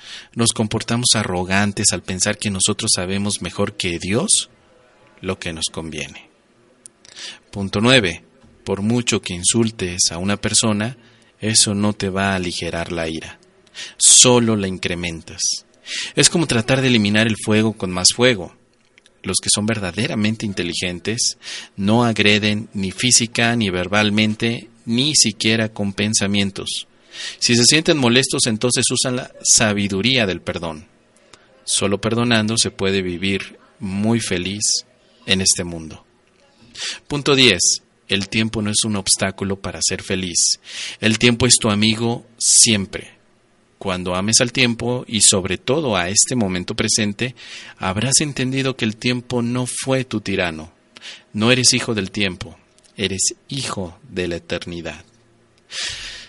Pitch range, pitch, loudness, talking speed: 95-120 Hz, 105 Hz, -17 LUFS, 135 wpm